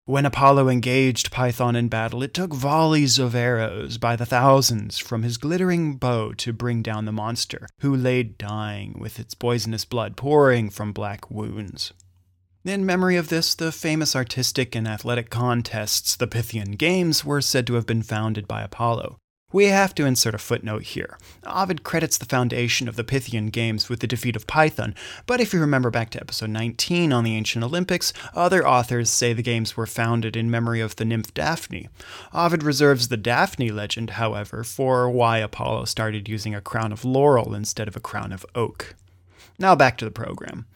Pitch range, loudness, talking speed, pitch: 110-135 Hz, -22 LUFS, 185 wpm, 120 Hz